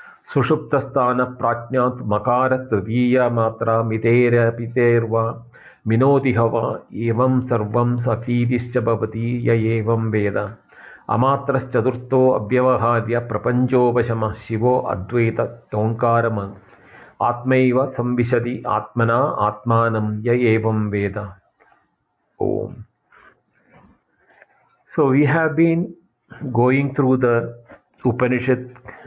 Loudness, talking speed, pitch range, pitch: -19 LUFS, 75 wpm, 115-125 Hz, 120 Hz